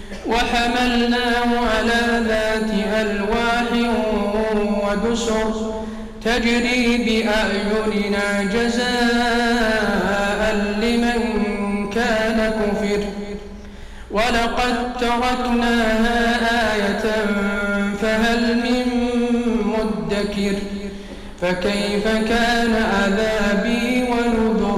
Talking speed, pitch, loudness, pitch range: 50 wpm, 220 Hz, -19 LUFS, 210-235 Hz